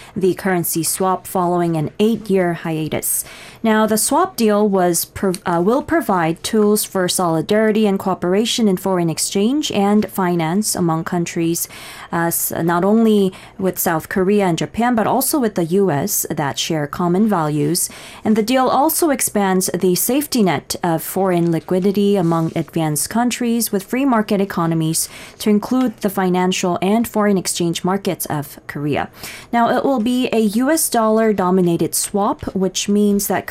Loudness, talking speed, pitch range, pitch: -17 LUFS, 150 wpm, 175-220 Hz, 190 Hz